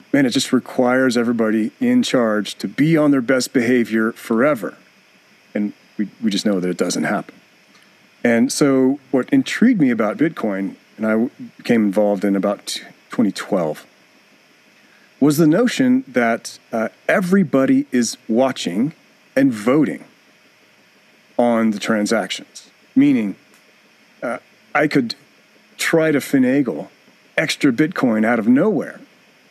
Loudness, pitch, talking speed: -18 LUFS, 135 Hz, 130 wpm